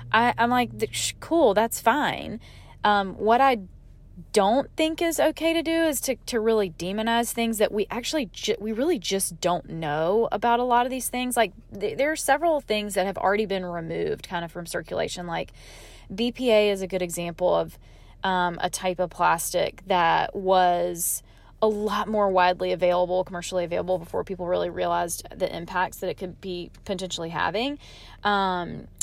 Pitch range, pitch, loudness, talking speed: 180-235 Hz, 205 Hz, -25 LUFS, 180 wpm